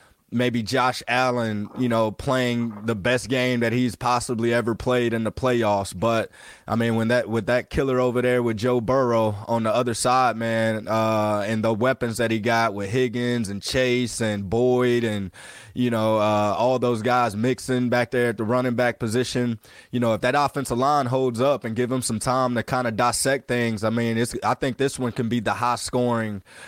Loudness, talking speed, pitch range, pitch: -23 LUFS, 210 wpm, 115-125 Hz, 120 Hz